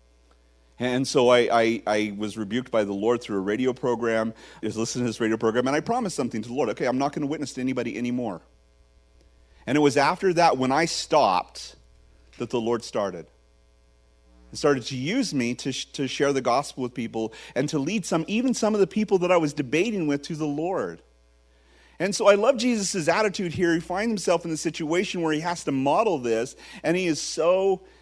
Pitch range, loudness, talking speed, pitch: 110-165 Hz, -24 LUFS, 220 wpm, 130 Hz